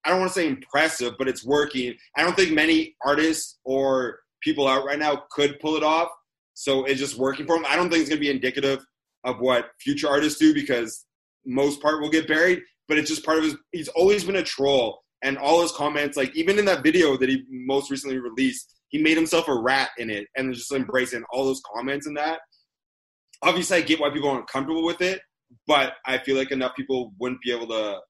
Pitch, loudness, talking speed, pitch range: 145 Hz, -23 LUFS, 230 wpm, 130-160 Hz